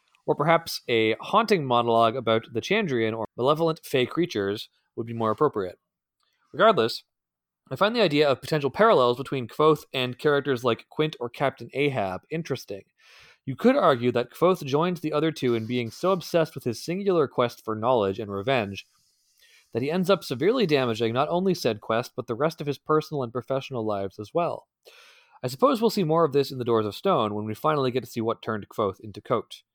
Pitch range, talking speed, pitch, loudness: 115-160 Hz, 200 wpm, 135 Hz, -25 LUFS